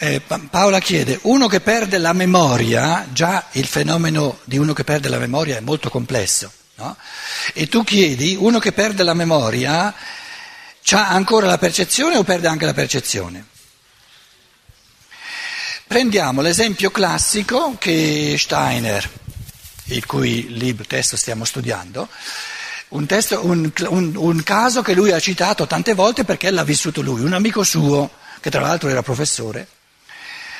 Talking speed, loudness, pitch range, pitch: 140 wpm, -17 LUFS, 135-205 Hz, 165 Hz